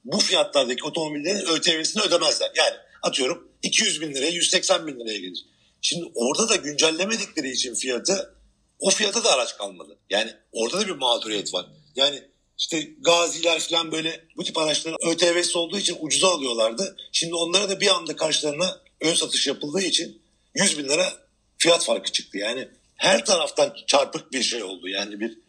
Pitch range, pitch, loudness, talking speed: 155-180 Hz, 165 Hz, -22 LUFS, 160 wpm